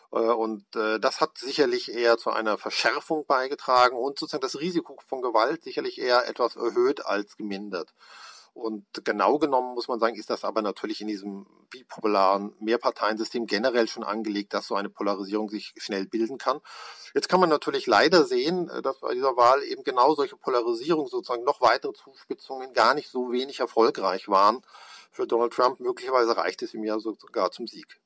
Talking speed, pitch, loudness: 175 wpm, 125 Hz, -26 LUFS